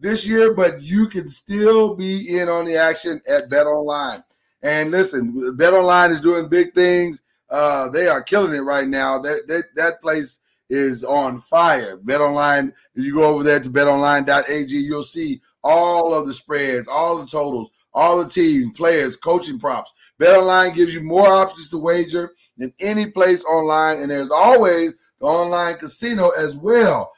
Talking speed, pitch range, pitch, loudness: 175 wpm, 145-190 Hz, 170 Hz, -17 LUFS